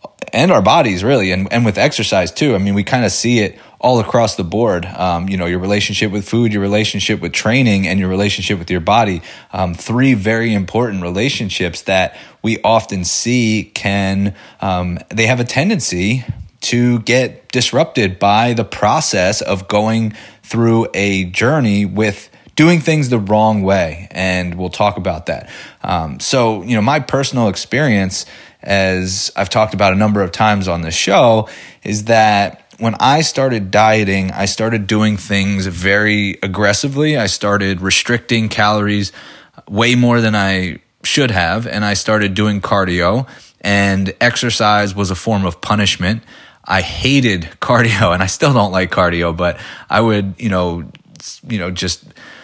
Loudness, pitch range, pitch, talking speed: -14 LUFS, 95-115 Hz, 105 Hz, 165 wpm